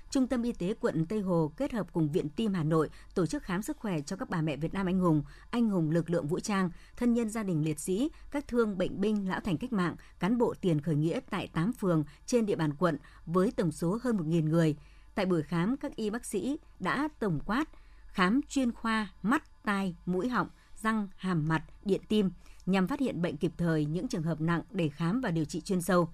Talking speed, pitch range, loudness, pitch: 240 wpm, 165-225 Hz, -31 LUFS, 185 Hz